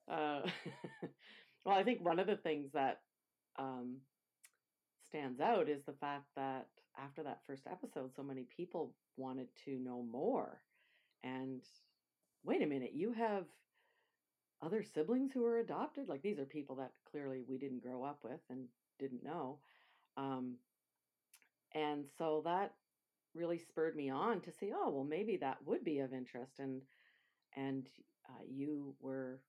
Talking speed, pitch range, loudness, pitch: 155 wpm, 130-170 Hz, -43 LUFS, 140 Hz